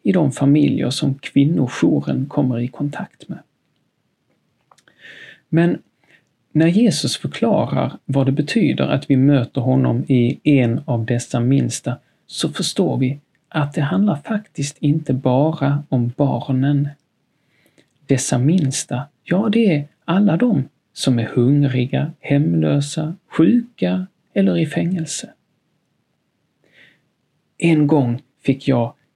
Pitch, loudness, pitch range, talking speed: 145 Hz, -18 LUFS, 130-165 Hz, 115 wpm